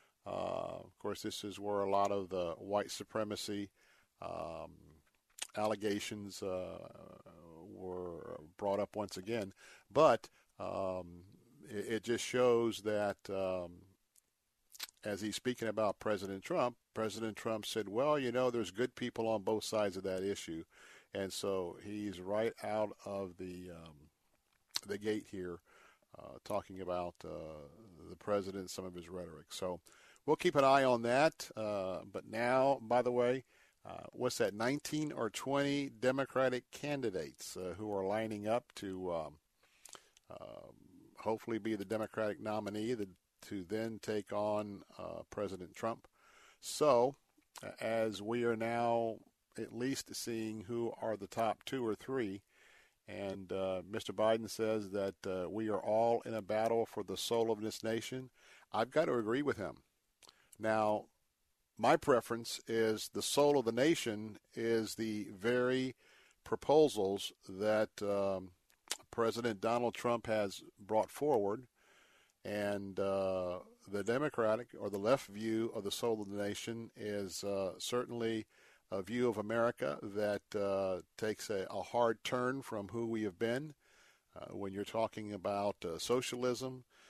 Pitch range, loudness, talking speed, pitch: 100-115 Hz, -37 LUFS, 145 wpm, 110 Hz